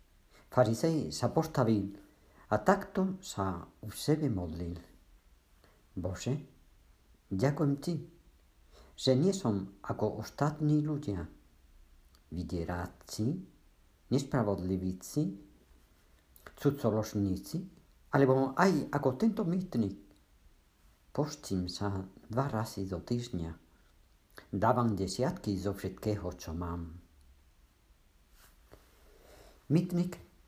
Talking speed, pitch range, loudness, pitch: 80 wpm, 80-130 Hz, -33 LUFS, 100 Hz